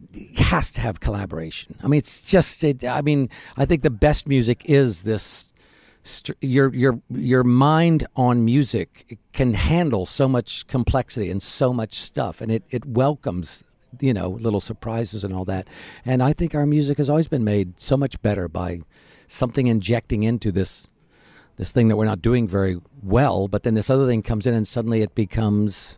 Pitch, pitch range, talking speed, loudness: 120 Hz, 105-135 Hz, 185 wpm, -21 LUFS